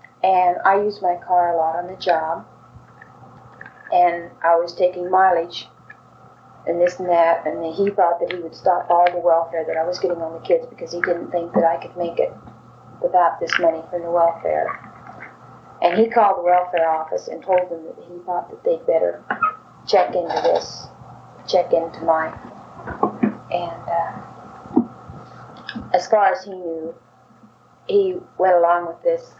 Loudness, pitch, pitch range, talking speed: -20 LUFS, 175 Hz, 170-185 Hz, 170 wpm